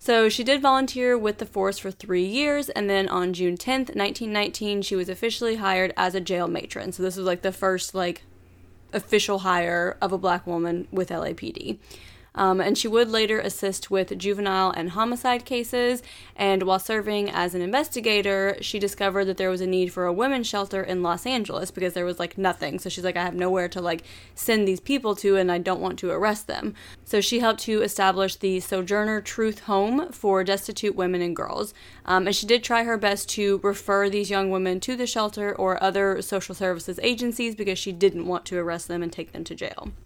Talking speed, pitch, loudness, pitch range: 210 wpm, 195 Hz, -25 LUFS, 185-215 Hz